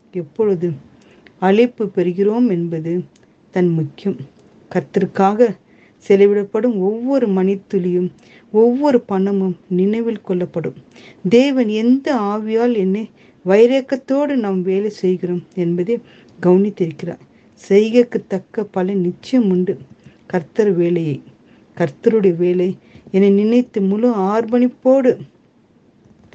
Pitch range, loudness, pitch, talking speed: 180-230 Hz, -17 LUFS, 195 Hz, 75 wpm